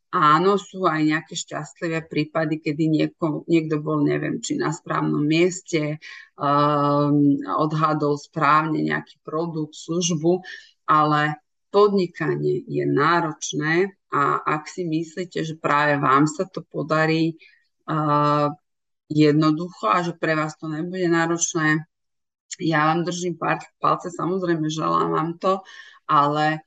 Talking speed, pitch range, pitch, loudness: 120 wpm, 150-170 Hz, 155 Hz, -22 LUFS